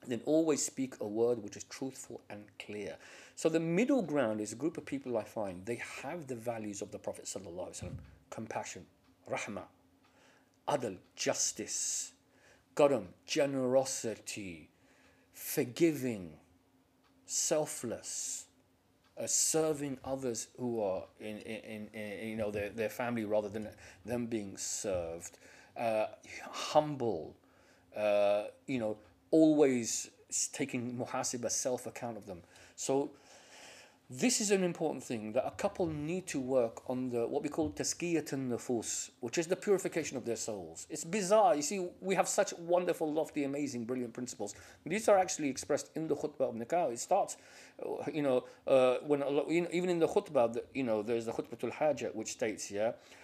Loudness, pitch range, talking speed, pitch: -34 LUFS, 110-155 Hz, 160 wpm, 130 Hz